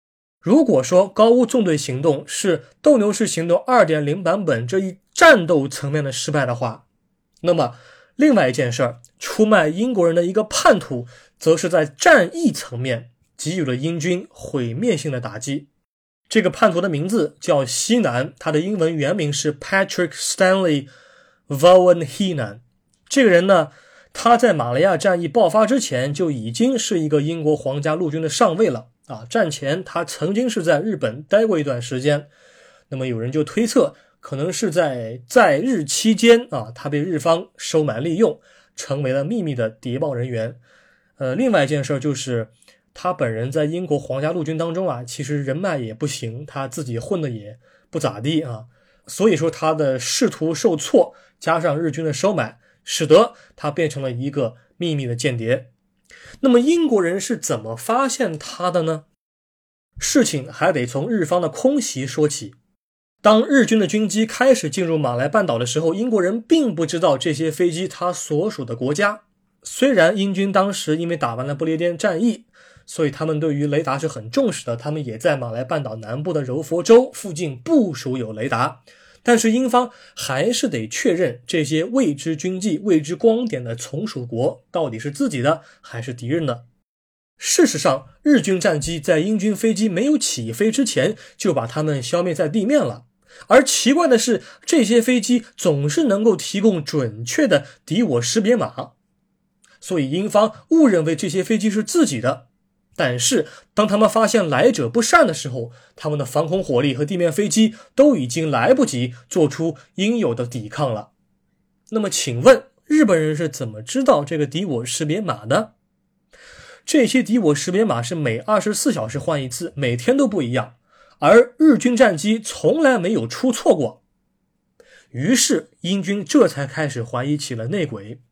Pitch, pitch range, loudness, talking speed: 165 Hz, 140-215 Hz, -19 LUFS, 270 characters per minute